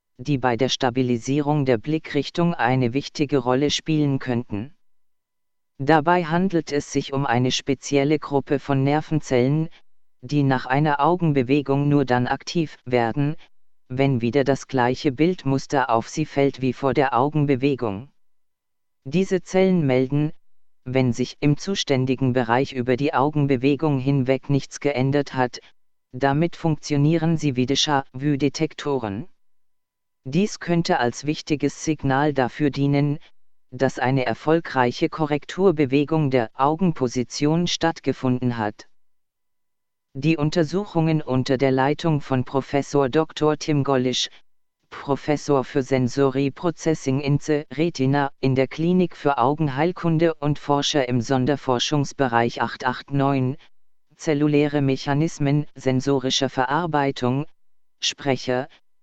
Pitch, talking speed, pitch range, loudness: 140 Hz, 110 wpm, 130-150 Hz, -22 LUFS